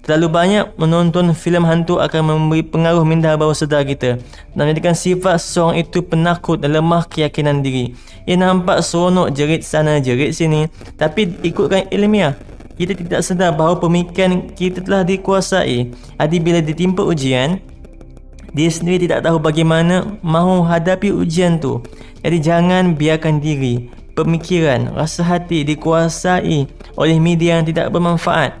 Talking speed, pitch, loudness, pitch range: 140 wpm, 165 Hz, -15 LUFS, 155-180 Hz